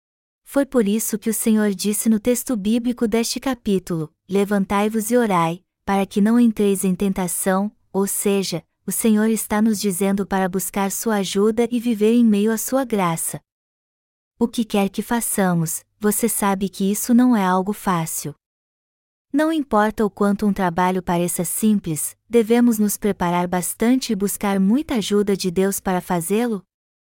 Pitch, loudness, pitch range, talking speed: 205 Hz, -20 LUFS, 190-225 Hz, 160 wpm